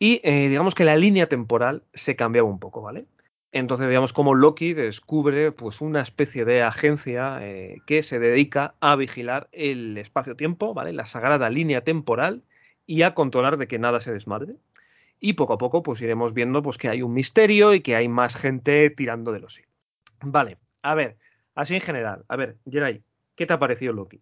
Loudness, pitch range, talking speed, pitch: -22 LUFS, 120-155 Hz, 195 wpm, 135 Hz